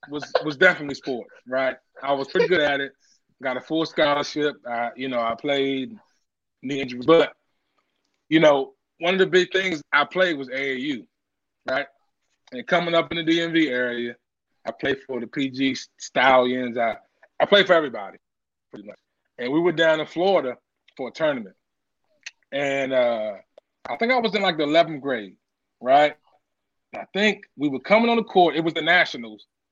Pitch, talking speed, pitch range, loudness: 150 Hz, 180 wpm, 130-180 Hz, -22 LUFS